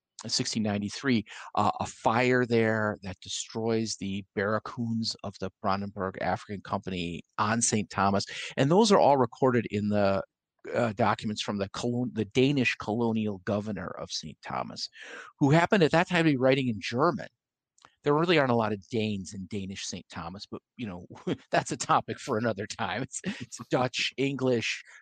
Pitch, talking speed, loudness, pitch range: 110 Hz, 170 wpm, -28 LUFS, 100-125 Hz